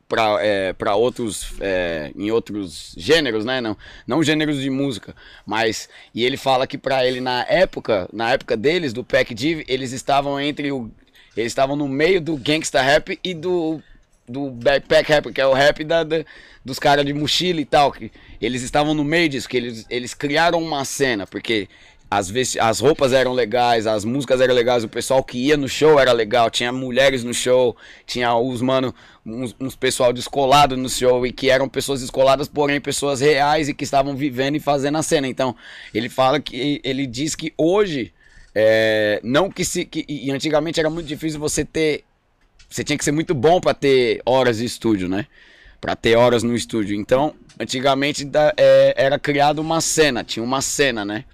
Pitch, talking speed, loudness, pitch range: 135 Hz, 195 wpm, -19 LUFS, 120-150 Hz